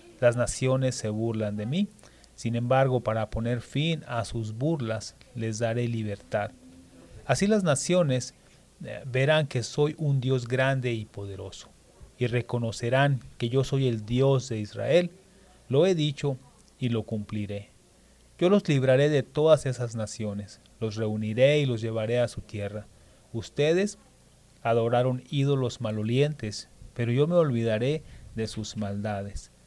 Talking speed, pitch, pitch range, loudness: 140 wpm, 120 Hz, 110-135 Hz, -27 LUFS